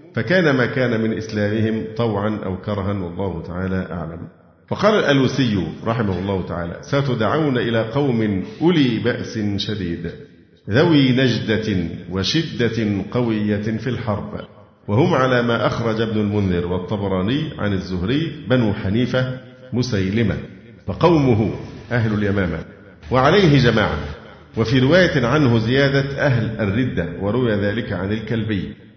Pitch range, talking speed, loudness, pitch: 100-130 Hz, 115 wpm, -19 LUFS, 110 Hz